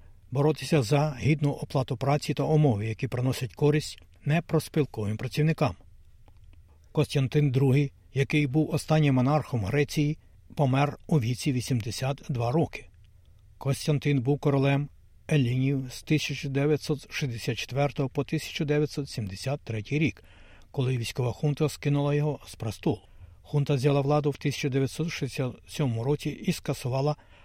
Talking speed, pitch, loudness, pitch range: 105 wpm, 140 Hz, -28 LUFS, 120-150 Hz